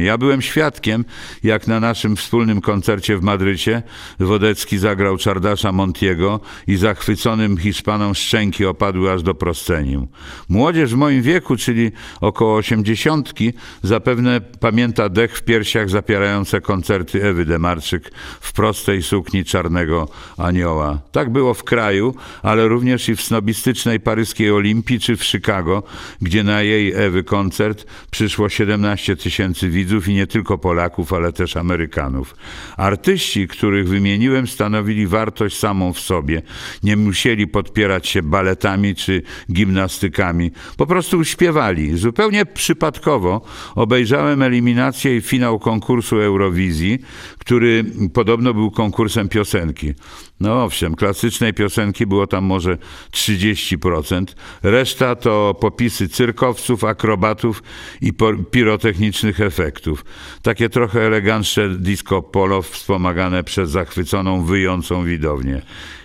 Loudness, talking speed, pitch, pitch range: -17 LUFS, 120 wpm, 105 Hz, 95-115 Hz